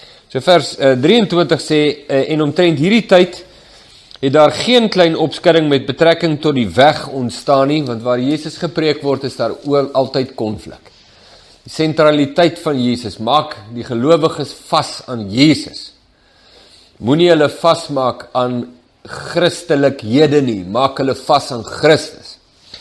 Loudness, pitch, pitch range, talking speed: -14 LUFS, 145 Hz, 130-160 Hz, 135 wpm